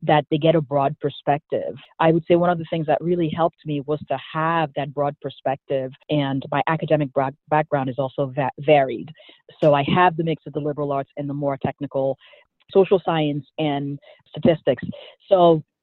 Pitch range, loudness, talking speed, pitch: 140-165 Hz, -22 LUFS, 190 wpm, 150 Hz